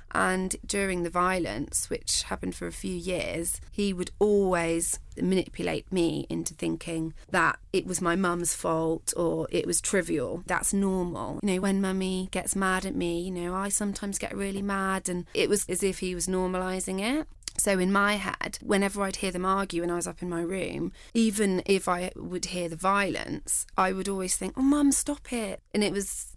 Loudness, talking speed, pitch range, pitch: -28 LUFS, 200 wpm, 175-200 Hz, 185 Hz